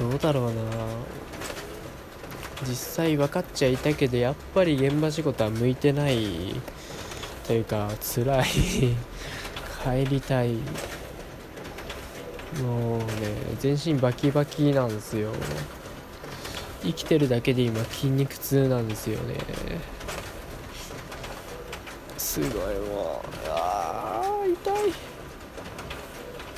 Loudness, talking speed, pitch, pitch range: -27 LUFS, 185 characters per minute, 130 Hz, 115-145 Hz